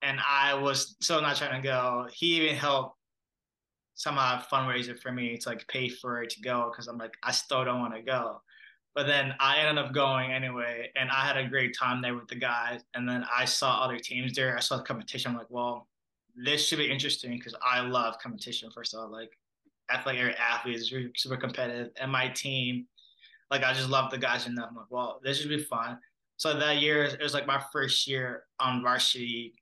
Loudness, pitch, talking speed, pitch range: -29 LUFS, 125 Hz, 220 wpm, 120-135 Hz